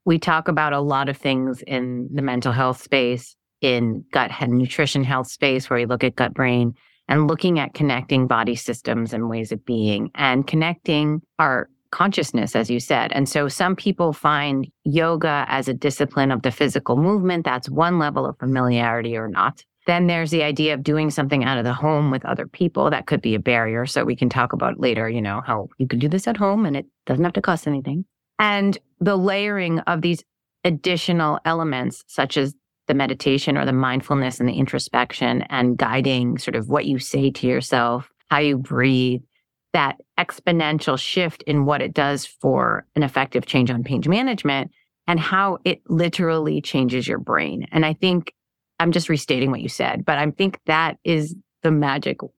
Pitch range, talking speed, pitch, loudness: 130-165 Hz, 190 wpm, 140 Hz, -21 LUFS